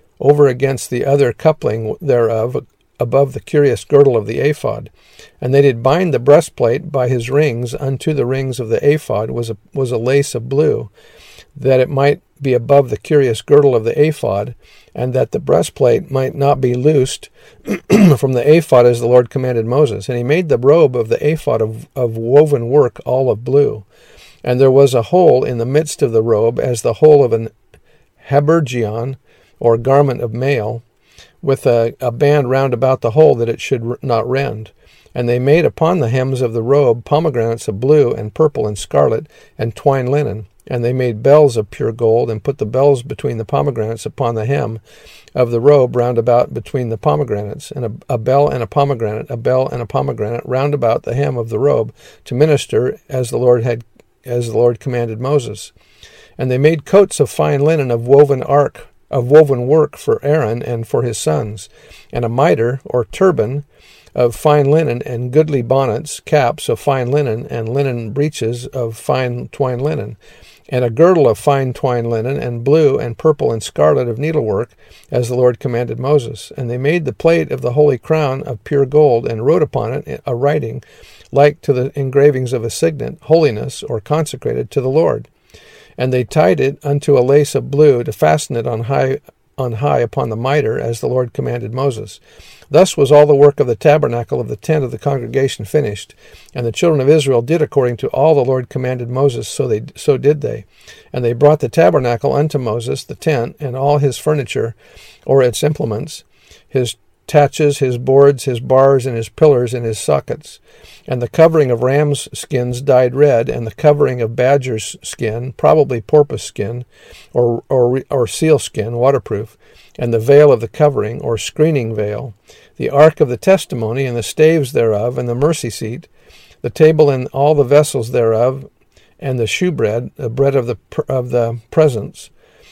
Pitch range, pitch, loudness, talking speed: 120-145 Hz, 135 Hz, -14 LUFS, 190 wpm